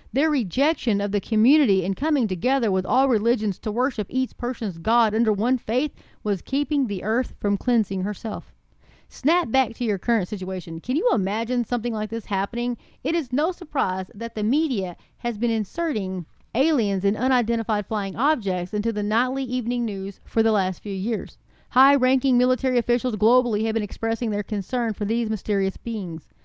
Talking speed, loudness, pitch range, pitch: 175 wpm, -24 LUFS, 205-255 Hz, 230 Hz